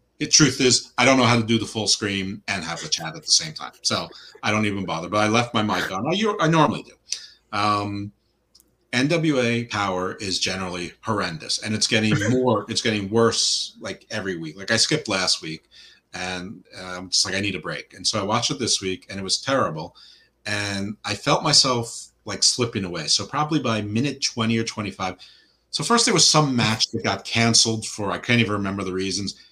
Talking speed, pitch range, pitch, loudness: 215 wpm, 100-120 Hz, 110 Hz, -21 LUFS